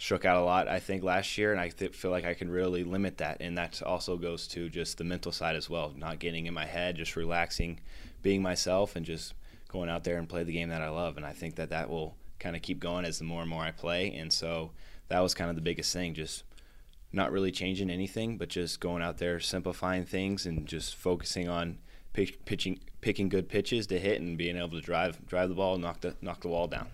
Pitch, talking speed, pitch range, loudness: 85 Hz, 250 wpm, 80-90 Hz, -33 LUFS